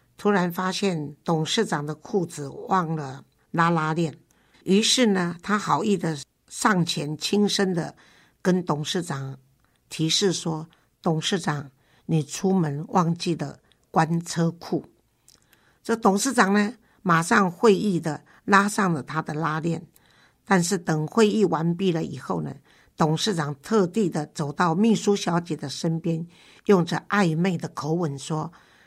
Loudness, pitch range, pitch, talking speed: -24 LUFS, 155-195 Hz, 170 Hz, 200 characters per minute